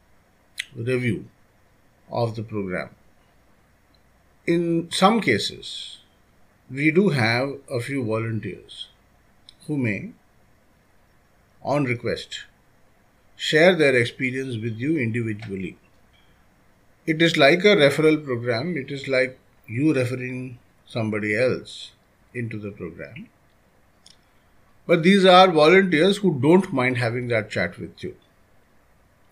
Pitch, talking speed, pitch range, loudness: 115 Hz, 105 wpm, 100-140 Hz, -21 LUFS